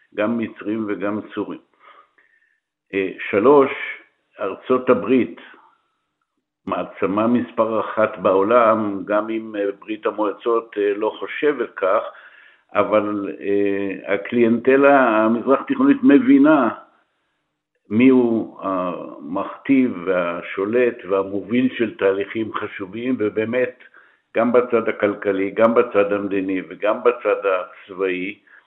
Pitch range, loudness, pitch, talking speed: 100-130 Hz, -19 LUFS, 110 Hz, 85 wpm